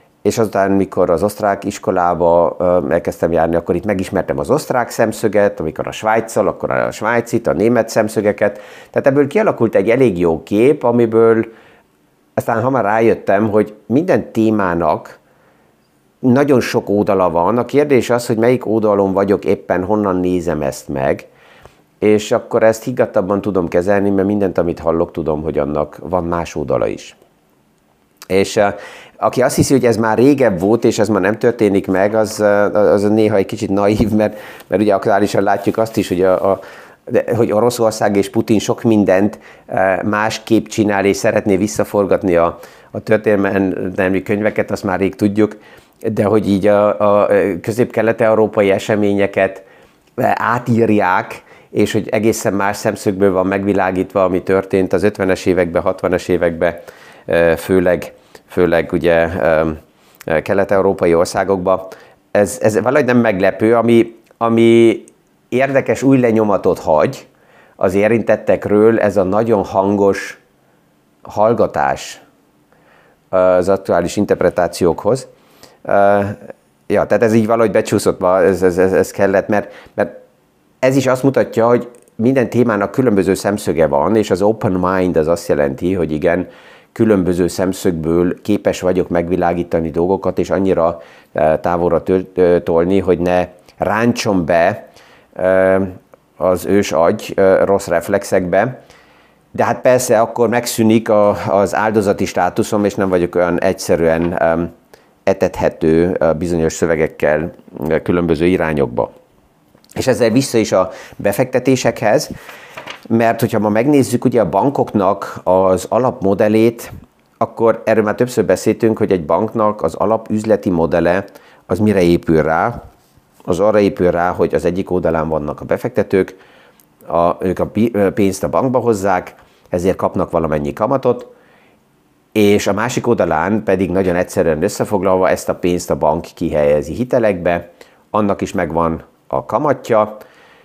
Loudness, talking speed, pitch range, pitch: -15 LUFS, 135 wpm, 90-110 Hz, 100 Hz